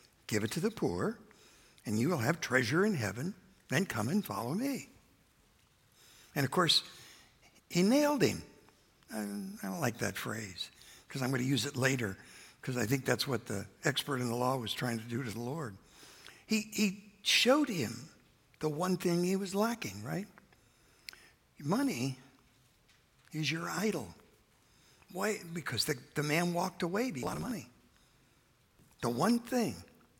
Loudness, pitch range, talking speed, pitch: -34 LUFS, 120-195 Hz, 165 wpm, 150 Hz